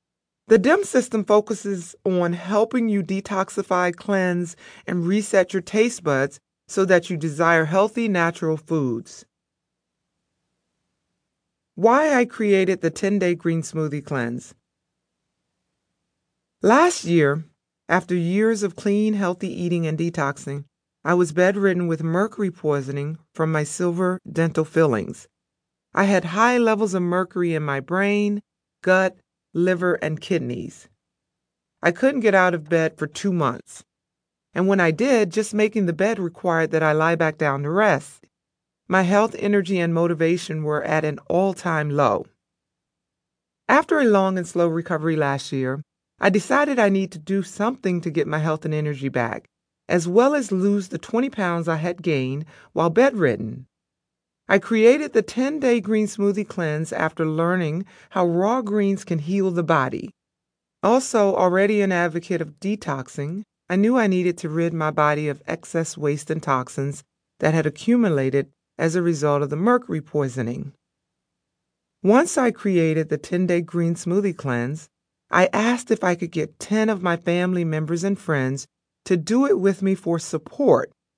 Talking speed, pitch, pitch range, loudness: 150 wpm, 175 Hz, 160-200 Hz, -21 LUFS